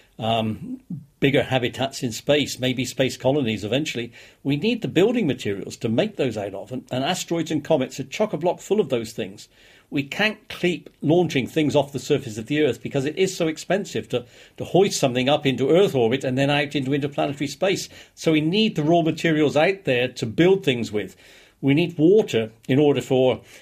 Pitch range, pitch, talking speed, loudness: 125-165 Hz, 140 Hz, 205 wpm, -22 LUFS